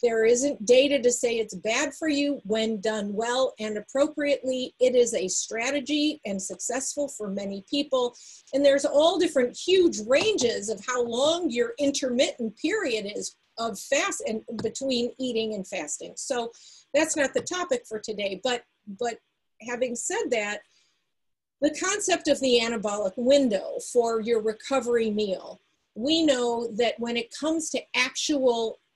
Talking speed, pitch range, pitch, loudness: 150 wpm, 225-290 Hz, 250 Hz, -26 LUFS